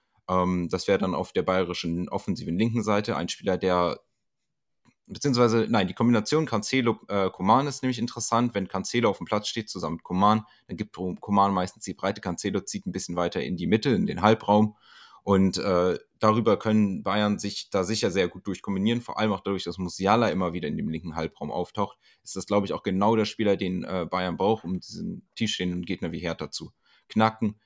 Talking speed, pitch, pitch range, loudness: 200 wpm, 100 Hz, 90-110 Hz, -26 LUFS